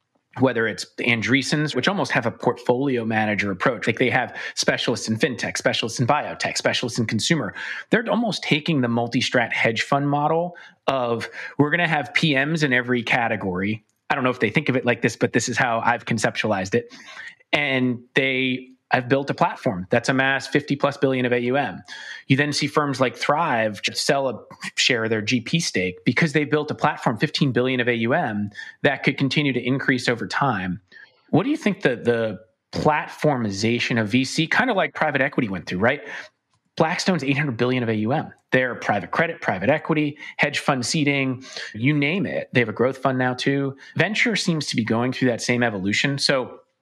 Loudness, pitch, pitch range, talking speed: -22 LUFS, 130 Hz, 120-145 Hz, 190 wpm